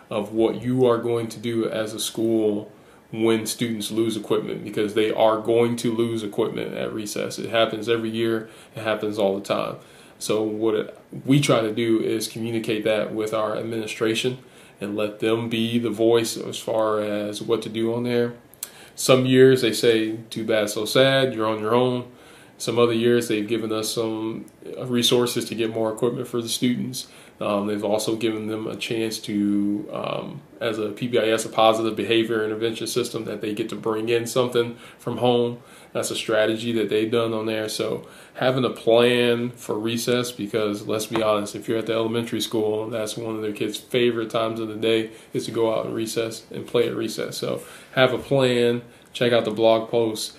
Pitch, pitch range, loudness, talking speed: 115 Hz, 110-120 Hz, -23 LUFS, 195 wpm